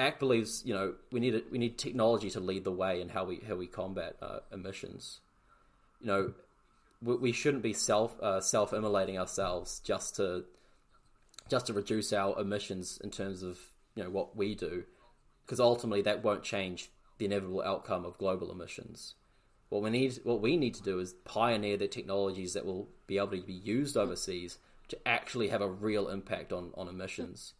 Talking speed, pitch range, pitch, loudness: 190 wpm, 95-115 Hz, 100 Hz, -34 LUFS